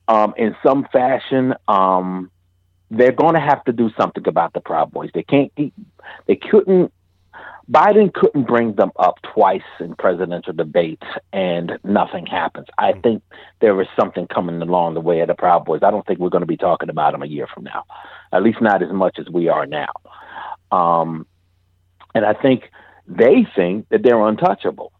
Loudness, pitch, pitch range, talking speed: -17 LUFS, 105 Hz, 90-135 Hz, 185 wpm